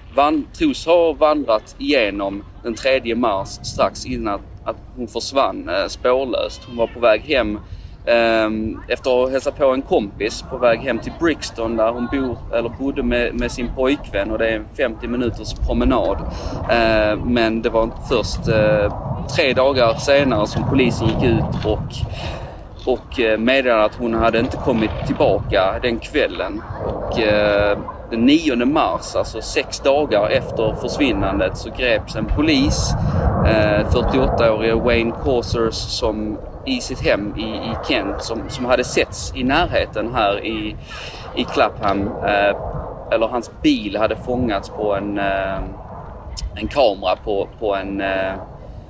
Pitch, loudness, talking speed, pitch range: 115 Hz, -19 LUFS, 145 wpm, 105-125 Hz